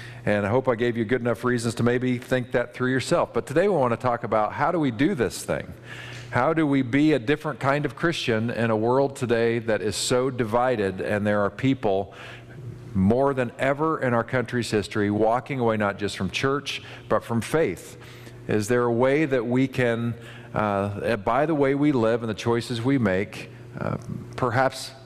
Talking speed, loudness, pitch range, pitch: 205 wpm, -24 LUFS, 115-130 Hz, 120 Hz